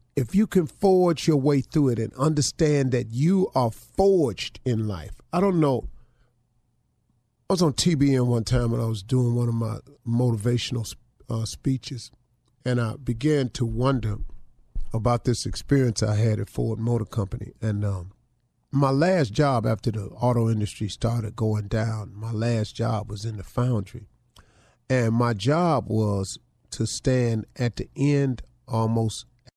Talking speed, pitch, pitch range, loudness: 160 wpm, 120 Hz, 110-135 Hz, -24 LUFS